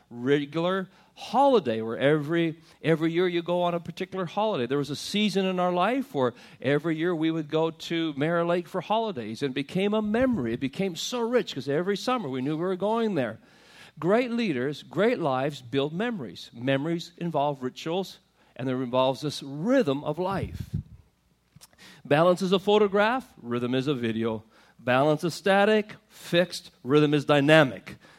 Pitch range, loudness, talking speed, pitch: 140-195 Hz, -26 LUFS, 170 wpm, 170 Hz